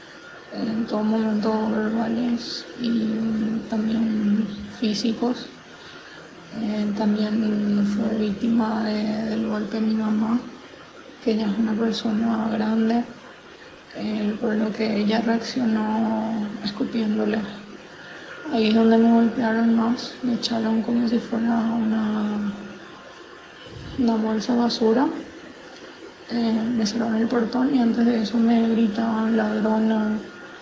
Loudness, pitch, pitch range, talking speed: -23 LUFS, 225 Hz, 215-230 Hz, 115 wpm